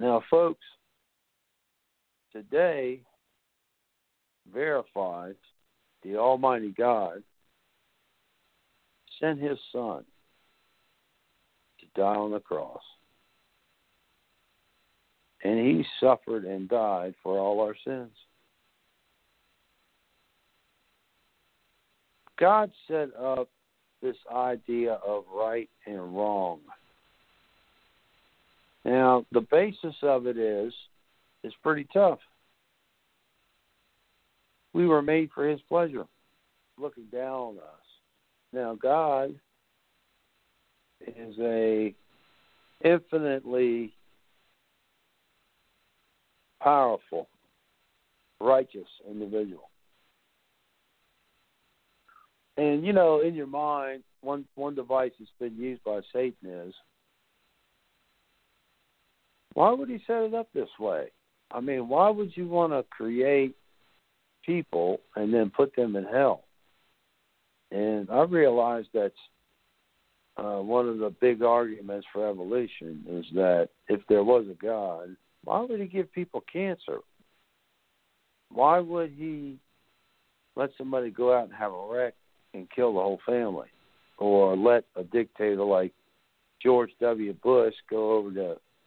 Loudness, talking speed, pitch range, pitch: -27 LUFS, 100 wpm, 105-145 Hz, 125 Hz